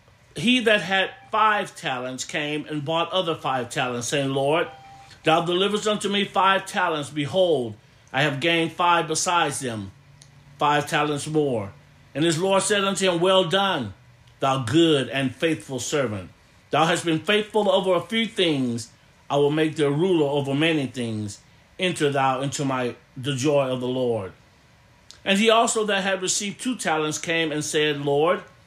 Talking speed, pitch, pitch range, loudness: 165 wpm, 150 Hz, 135-185 Hz, -23 LUFS